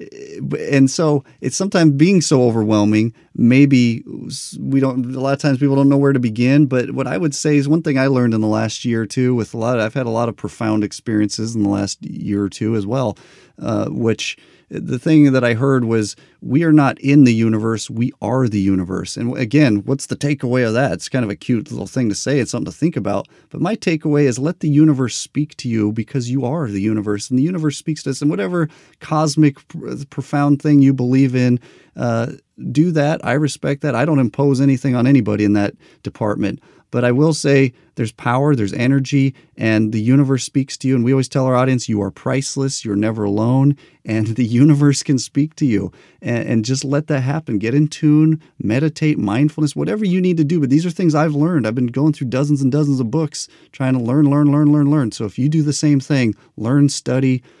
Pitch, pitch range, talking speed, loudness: 135 Hz, 115-150 Hz, 225 wpm, -17 LUFS